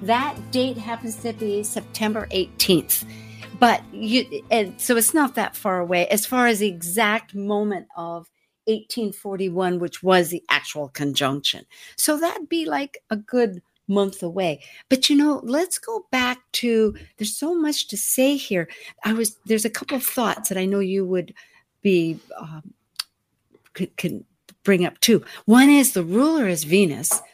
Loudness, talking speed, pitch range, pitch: -21 LUFS, 160 wpm, 185-245 Hz, 215 Hz